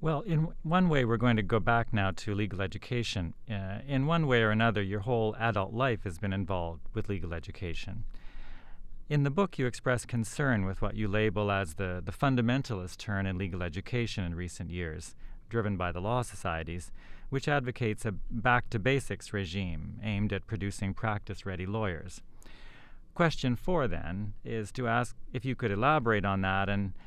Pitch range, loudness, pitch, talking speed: 95-120 Hz, -32 LUFS, 105 Hz, 180 wpm